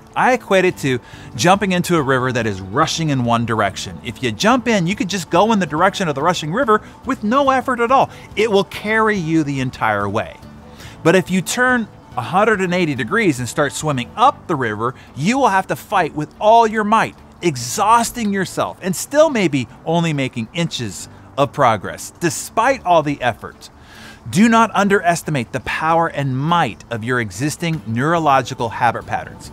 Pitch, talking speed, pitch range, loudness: 155 Hz, 180 wpm, 125-195 Hz, -17 LUFS